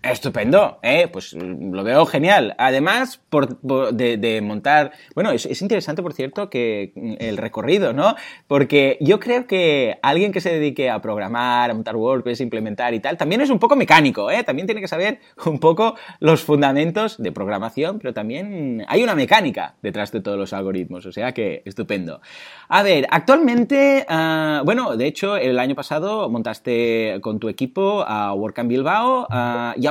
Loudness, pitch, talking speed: -19 LUFS, 140 Hz, 175 wpm